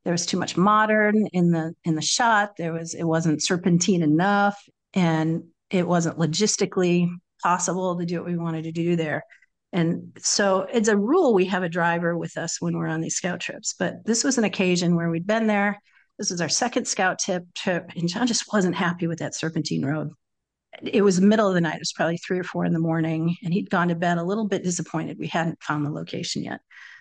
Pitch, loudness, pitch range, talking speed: 175 Hz, -23 LUFS, 165-200 Hz, 225 wpm